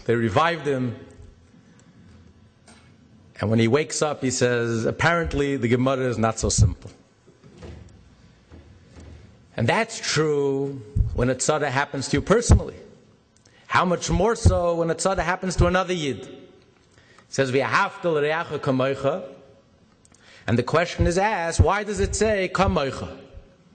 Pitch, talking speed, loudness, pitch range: 135 Hz, 130 wpm, -22 LUFS, 115-165 Hz